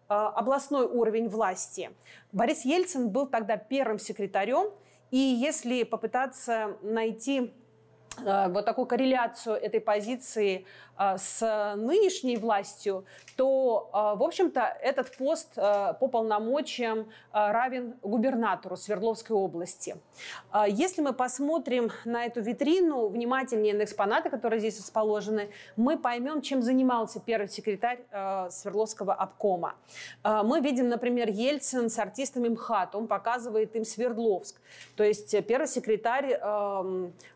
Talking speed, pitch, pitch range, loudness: 110 wpm, 230 Hz, 210-255 Hz, -29 LUFS